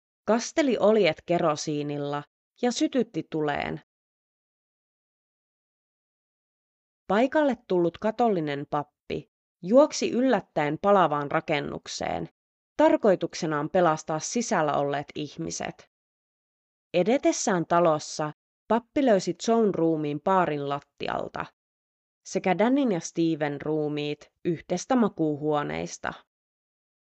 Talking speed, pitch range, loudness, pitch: 75 wpm, 150-215 Hz, -26 LUFS, 170 Hz